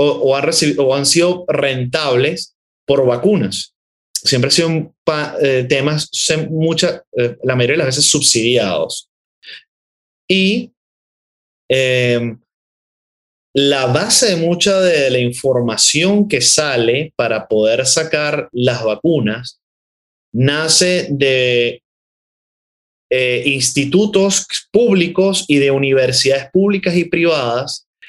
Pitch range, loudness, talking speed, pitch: 125-170 Hz, -14 LUFS, 110 wpm, 140 Hz